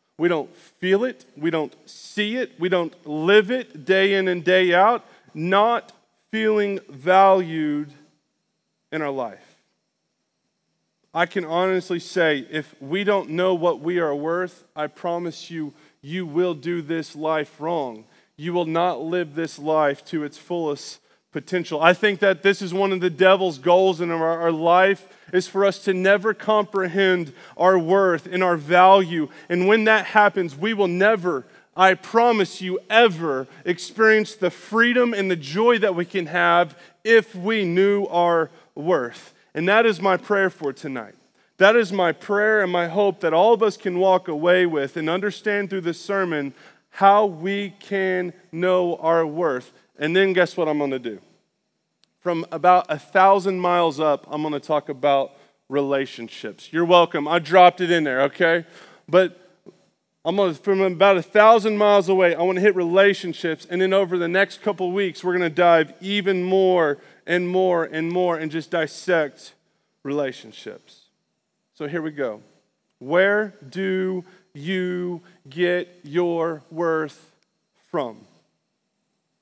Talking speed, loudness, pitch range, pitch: 155 wpm, -20 LUFS, 160-195 Hz, 180 Hz